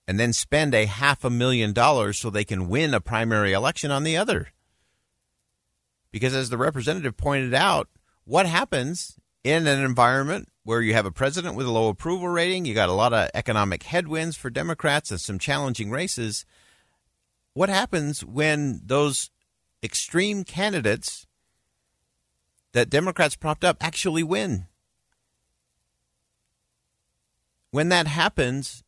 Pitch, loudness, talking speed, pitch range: 130 Hz, -23 LUFS, 140 wpm, 105-160 Hz